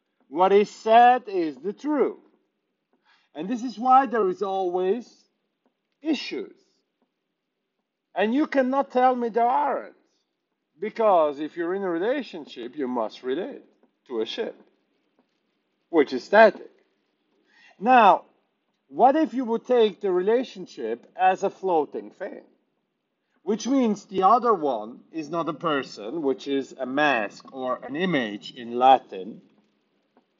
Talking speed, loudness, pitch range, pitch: 130 wpm, -23 LUFS, 175-255 Hz, 210 Hz